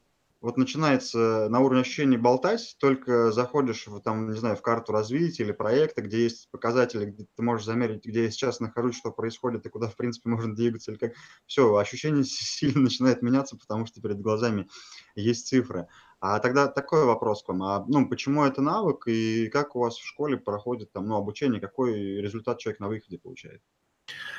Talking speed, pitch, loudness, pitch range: 185 wpm, 115 Hz, -27 LUFS, 110-130 Hz